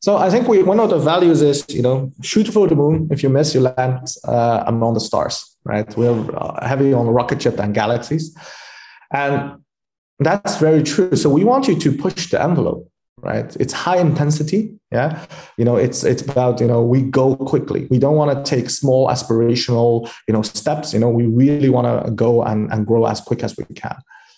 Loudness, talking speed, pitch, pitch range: -17 LUFS, 210 wpm, 130 Hz, 120-150 Hz